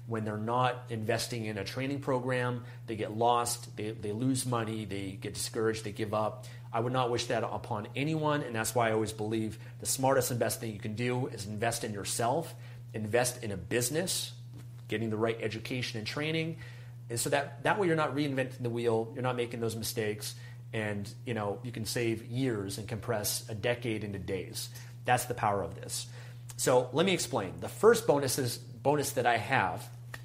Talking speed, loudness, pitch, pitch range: 200 wpm, -32 LUFS, 120 Hz, 110-125 Hz